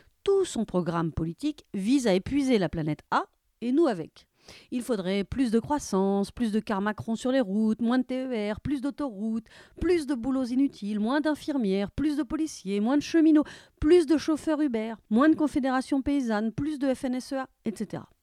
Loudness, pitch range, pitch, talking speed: -27 LUFS, 215-295 Hz, 255 Hz, 180 wpm